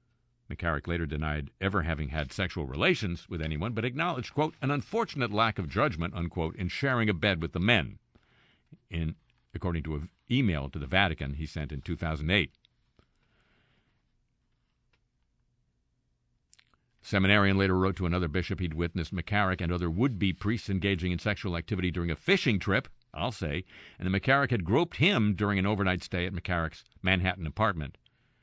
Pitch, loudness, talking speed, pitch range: 95 Hz, -29 LUFS, 160 wpm, 85-105 Hz